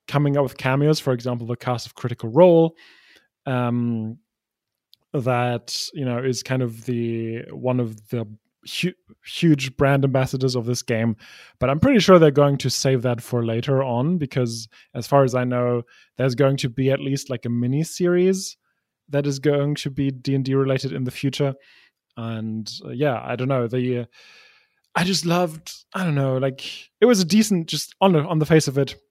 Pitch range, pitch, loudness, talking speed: 120-150 Hz, 135 Hz, -21 LUFS, 195 wpm